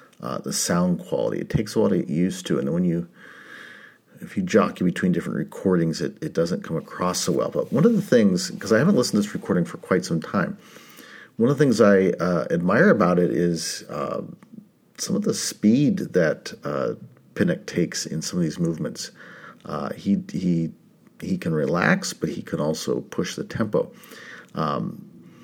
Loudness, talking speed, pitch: -23 LUFS, 190 wpm, 90 Hz